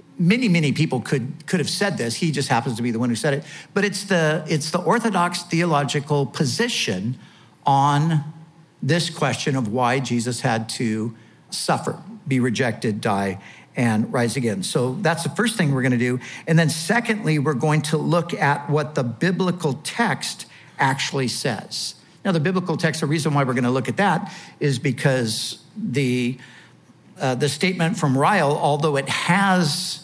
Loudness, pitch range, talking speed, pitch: -21 LUFS, 130-175 Hz, 175 wpm, 150 Hz